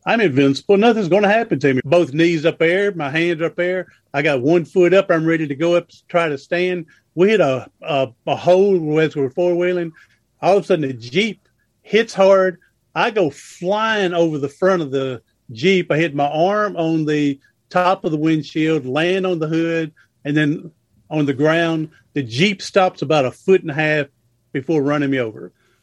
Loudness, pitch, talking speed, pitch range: -18 LUFS, 165 Hz, 205 wpm, 145-180 Hz